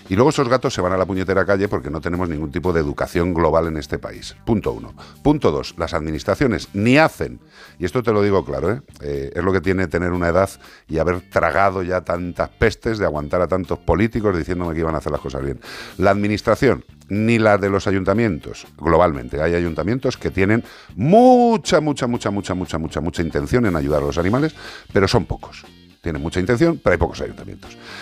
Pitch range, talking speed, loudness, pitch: 85-105 Hz, 210 wpm, -19 LUFS, 90 Hz